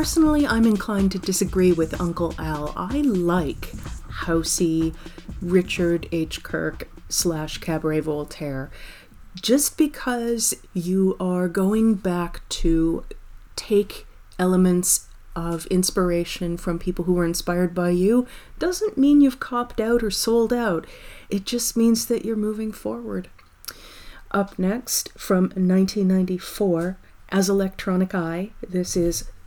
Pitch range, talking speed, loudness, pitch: 170-220 Hz, 120 wpm, -22 LUFS, 185 Hz